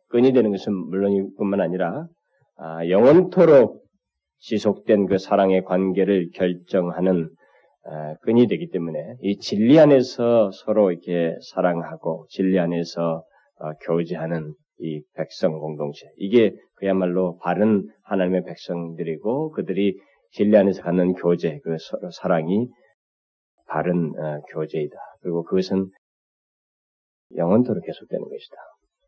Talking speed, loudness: 260 characters per minute, -21 LUFS